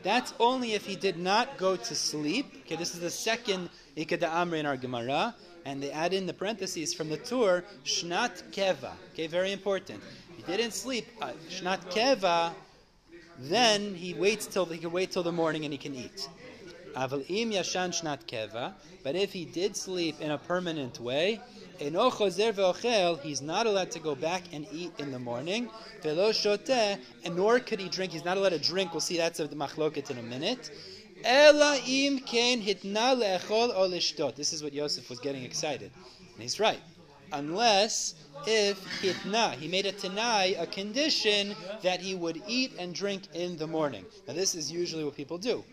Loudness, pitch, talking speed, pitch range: -29 LUFS, 180 Hz, 165 wpm, 155-205 Hz